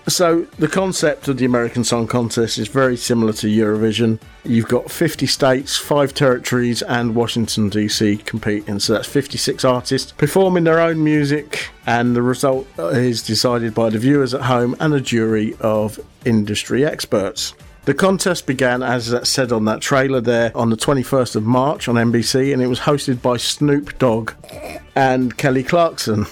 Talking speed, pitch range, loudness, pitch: 170 wpm, 115-140 Hz, -17 LUFS, 125 Hz